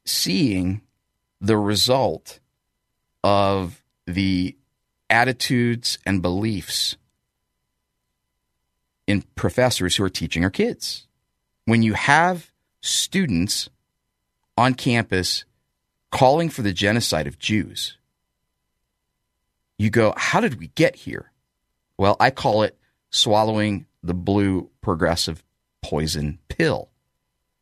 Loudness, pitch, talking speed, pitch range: -21 LUFS, 95 Hz, 95 wpm, 75-110 Hz